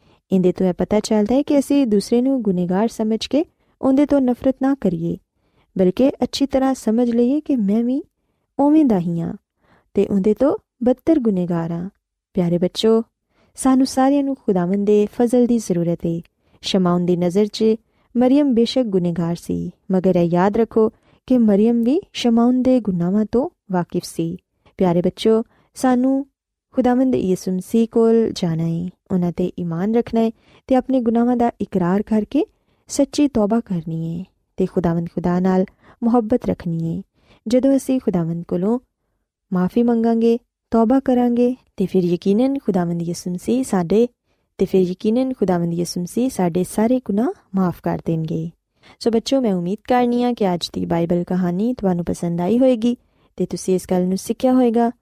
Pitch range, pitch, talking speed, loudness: 180-245 Hz, 215 Hz, 155 wpm, -19 LUFS